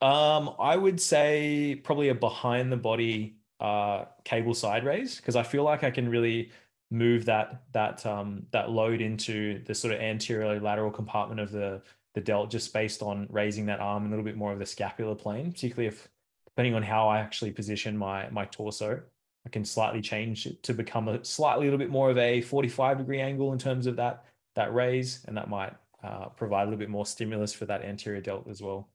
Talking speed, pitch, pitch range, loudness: 215 wpm, 110 Hz, 105-125 Hz, -29 LUFS